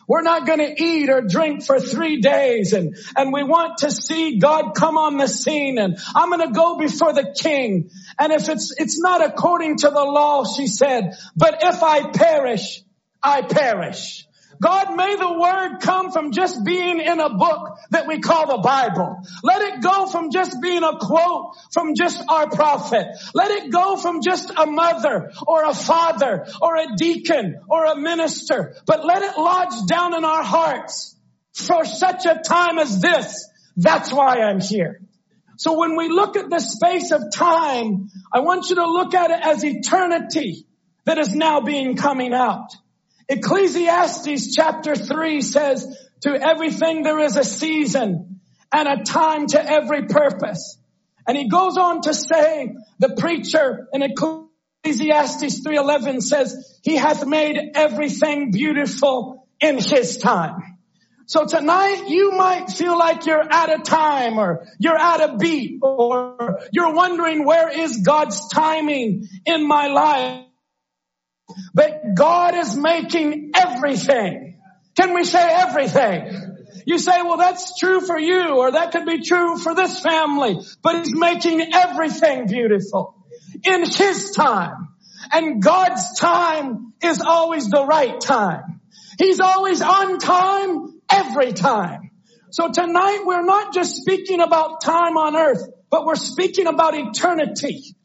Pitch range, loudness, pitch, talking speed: 260-335 Hz, -18 LUFS, 310 Hz, 155 wpm